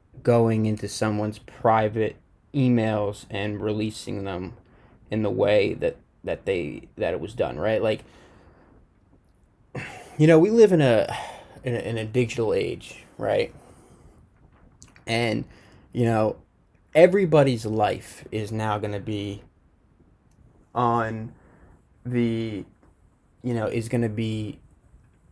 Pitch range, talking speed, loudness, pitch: 105-125 Hz, 120 wpm, -24 LUFS, 110 Hz